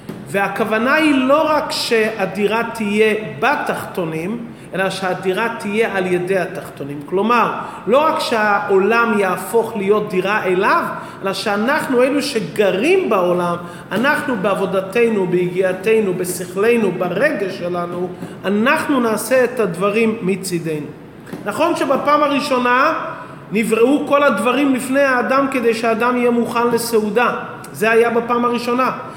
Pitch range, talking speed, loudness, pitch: 190-255 Hz, 110 wpm, -17 LUFS, 220 Hz